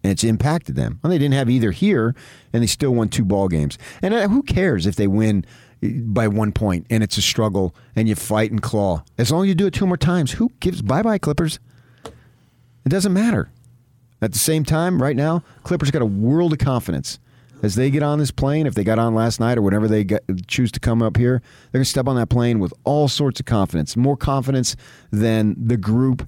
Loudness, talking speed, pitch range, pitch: -19 LUFS, 235 wpm, 110-140 Hz, 120 Hz